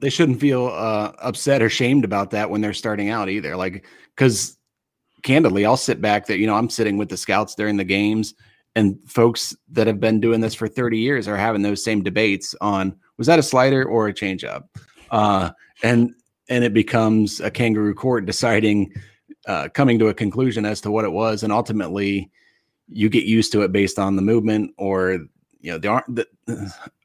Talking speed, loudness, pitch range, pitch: 205 wpm, -20 LUFS, 105-115 Hz, 110 Hz